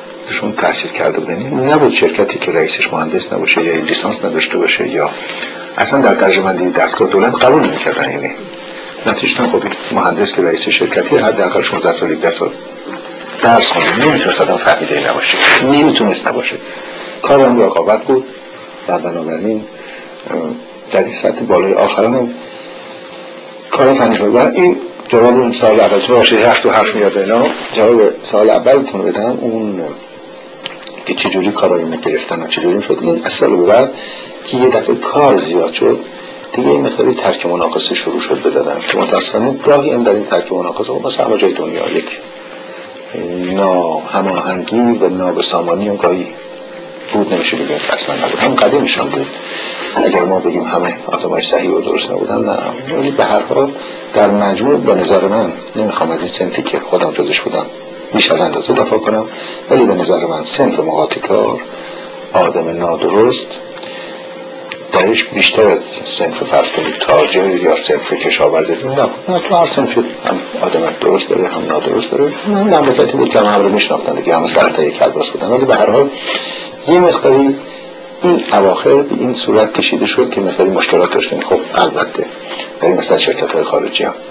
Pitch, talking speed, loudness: 360 Hz, 165 wpm, -12 LUFS